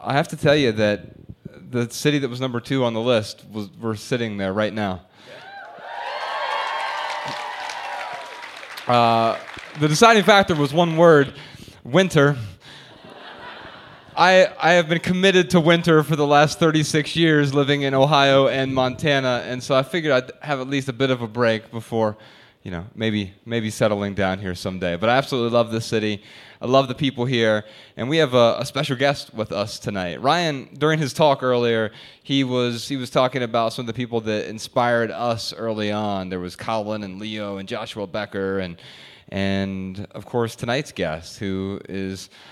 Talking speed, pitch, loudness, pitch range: 175 wpm, 120 Hz, -21 LUFS, 105-140 Hz